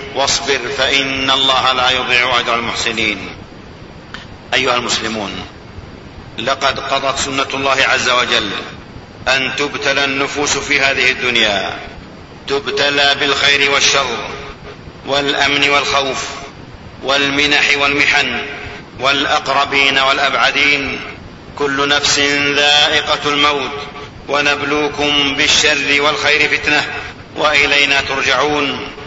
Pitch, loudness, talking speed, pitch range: 140 Hz, -13 LUFS, 85 wpm, 130-145 Hz